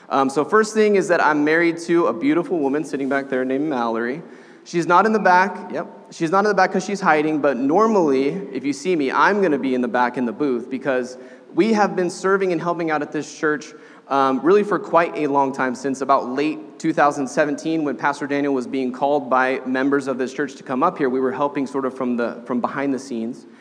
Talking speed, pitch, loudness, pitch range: 240 wpm, 145 Hz, -20 LUFS, 130-175 Hz